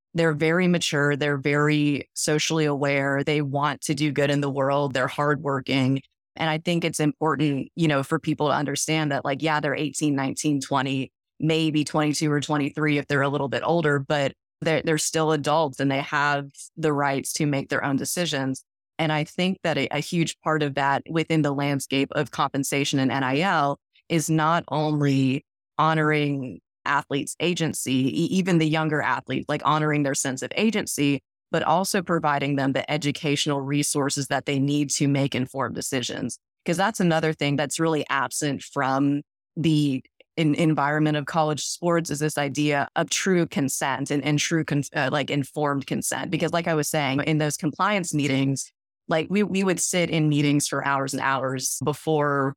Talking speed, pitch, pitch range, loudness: 180 wpm, 145 Hz, 140-155 Hz, -24 LUFS